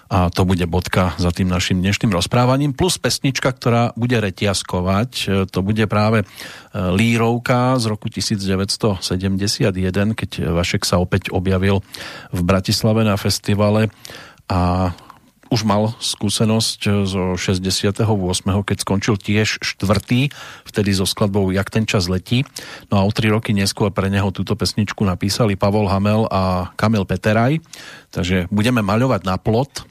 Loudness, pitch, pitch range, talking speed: -18 LUFS, 105 Hz, 95-115 Hz, 135 wpm